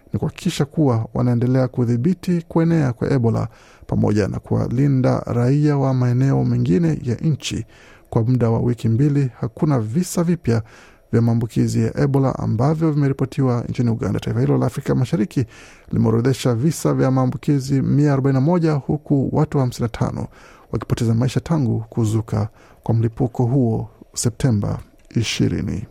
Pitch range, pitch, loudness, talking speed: 115-140 Hz, 125 Hz, -20 LUFS, 125 wpm